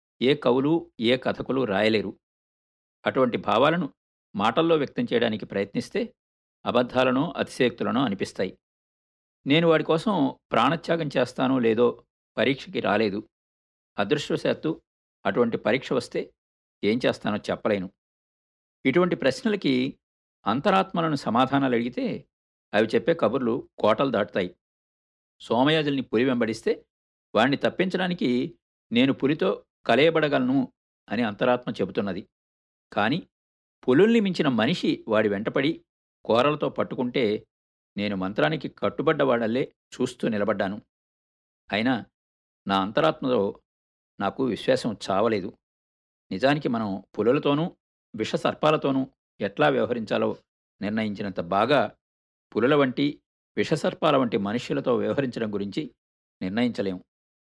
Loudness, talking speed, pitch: -25 LUFS, 90 wpm, 125 Hz